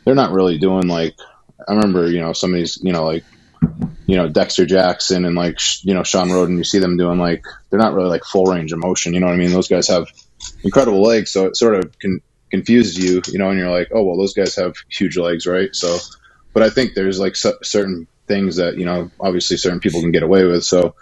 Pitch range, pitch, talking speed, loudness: 85-95 Hz, 90 Hz, 245 wpm, -16 LUFS